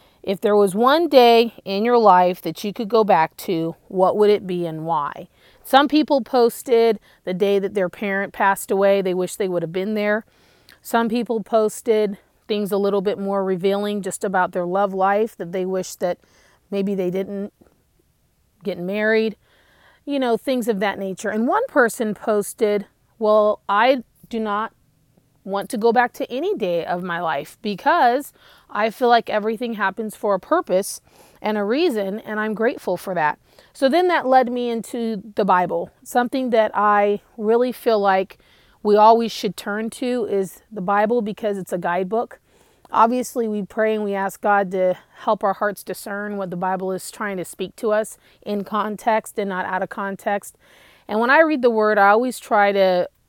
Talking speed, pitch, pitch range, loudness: 185 wpm, 210 Hz, 195-230 Hz, -20 LUFS